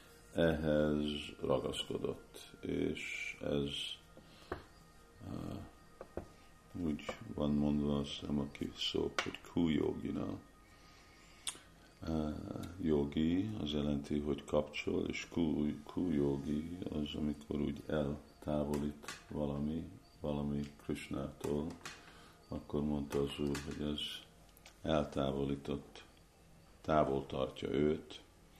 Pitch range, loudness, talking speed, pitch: 70-80 Hz, -38 LUFS, 90 wpm, 75 Hz